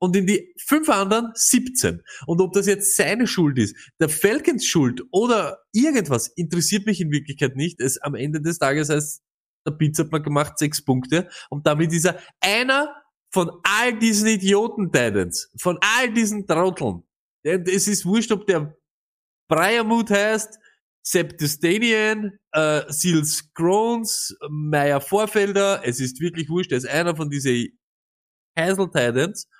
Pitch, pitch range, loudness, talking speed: 175 Hz, 150-210 Hz, -21 LUFS, 150 wpm